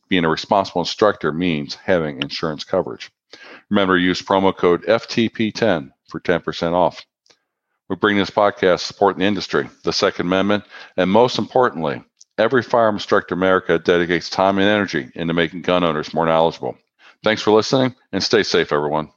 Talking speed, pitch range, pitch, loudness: 160 wpm, 85-105 Hz, 95 Hz, -18 LUFS